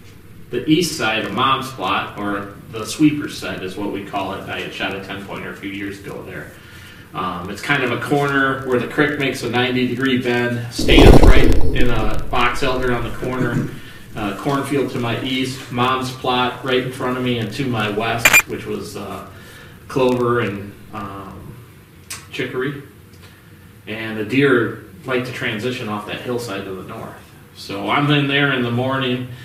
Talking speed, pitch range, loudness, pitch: 185 wpm, 100-130 Hz, -19 LUFS, 120 Hz